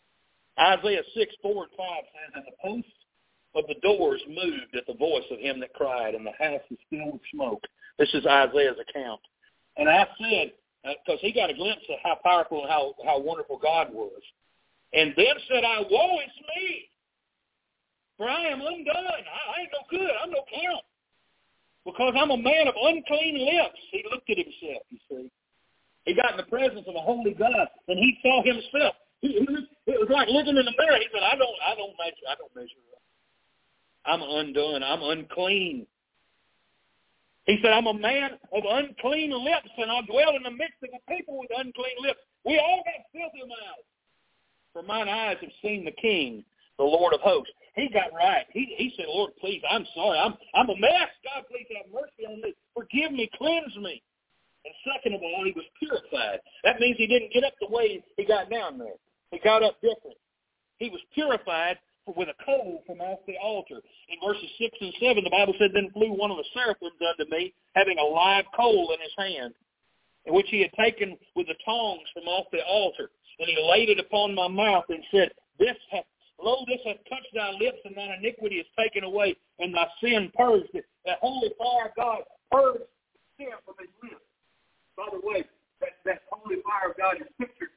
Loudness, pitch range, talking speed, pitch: -26 LUFS, 195-320 Hz, 200 wpm, 245 Hz